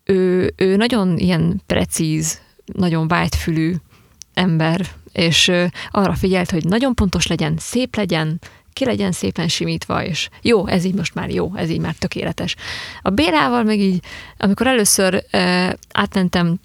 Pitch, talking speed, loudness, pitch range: 185 Hz, 150 wpm, -18 LUFS, 170-200 Hz